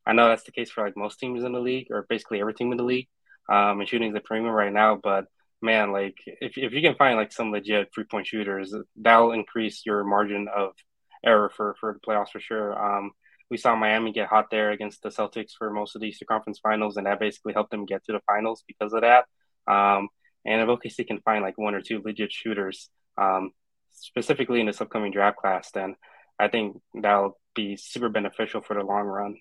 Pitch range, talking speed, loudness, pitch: 100-110 Hz, 230 wpm, -25 LUFS, 105 Hz